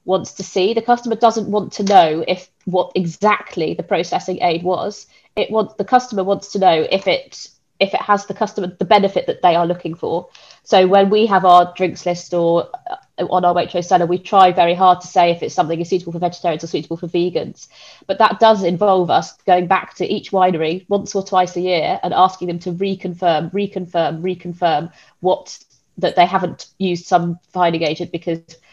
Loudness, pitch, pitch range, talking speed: -17 LUFS, 185 Hz, 175-195 Hz, 205 wpm